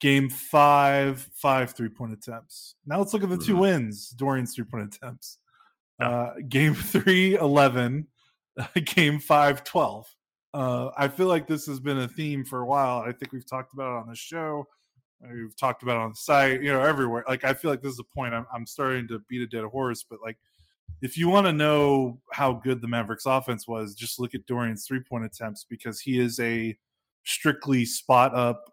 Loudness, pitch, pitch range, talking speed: -25 LUFS, 130 Hz, 120-145 Hz, 205 wpm